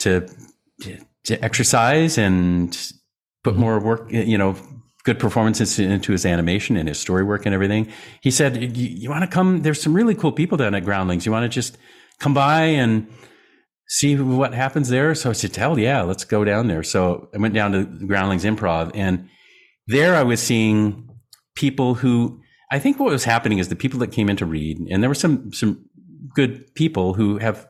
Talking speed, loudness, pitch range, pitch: 195 wpm, -20 LUFS, 100-130 Hz, 110 Hz